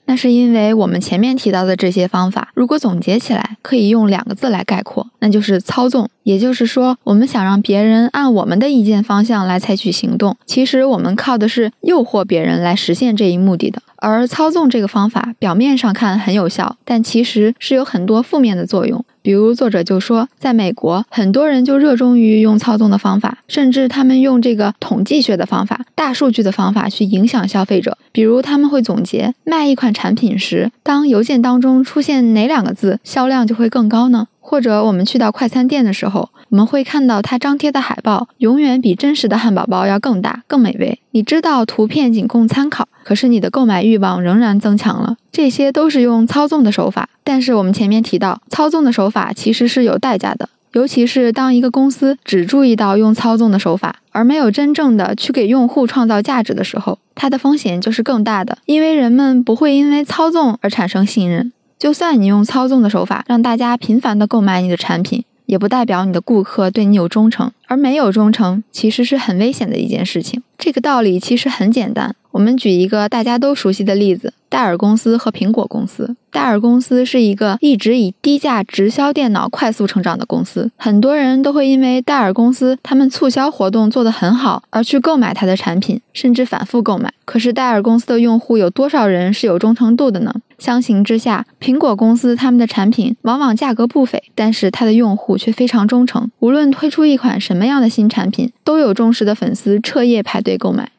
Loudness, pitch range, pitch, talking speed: -13 LUFS, 210-255 Hz, 230 Hz, 325 characters per minute